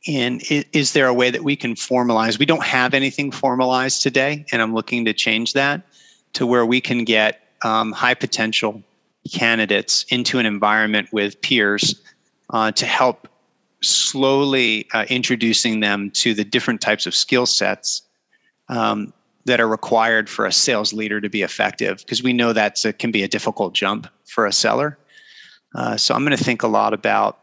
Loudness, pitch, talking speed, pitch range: -18 LUFS, 120 Hz, 175 wpm, 110-130 Hz